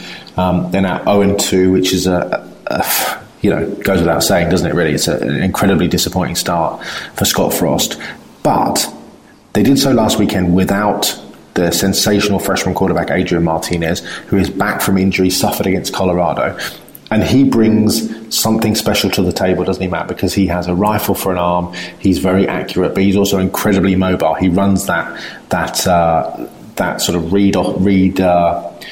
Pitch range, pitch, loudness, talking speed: 90-100 Hz, 95 Hz, -14 LUFS, 185 wpm